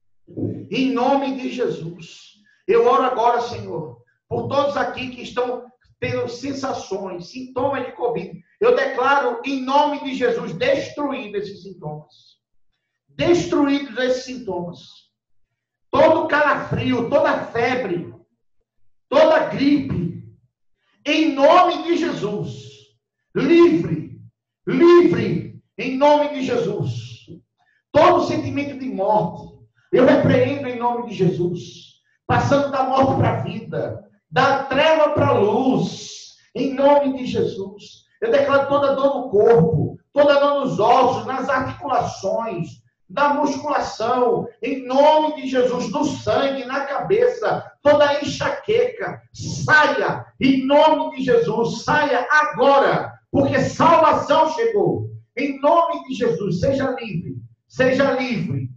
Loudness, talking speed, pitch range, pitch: -19 LUFS, 115 wpm, 195-285 Hz, 255 Hz